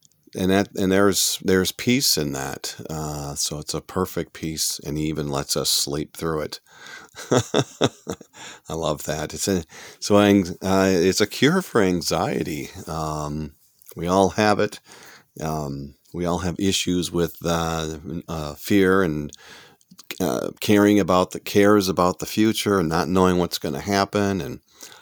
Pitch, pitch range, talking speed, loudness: 90 Hz, 80-100 Hz, 155 wpm, -22 LUFS